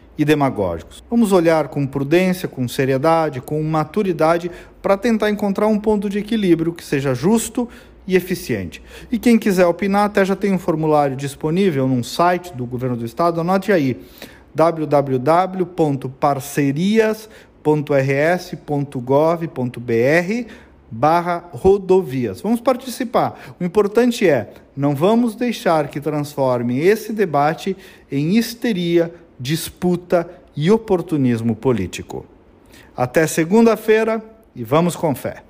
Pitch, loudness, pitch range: 170 Hz, -18 LUFS, 140-200 Hz